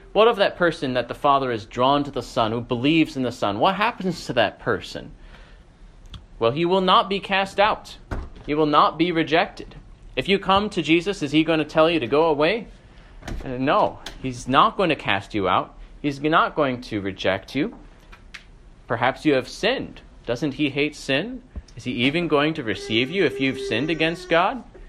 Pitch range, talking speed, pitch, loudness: 125-175 Hz, 200 wpm, 150 Hz, -22 LUFS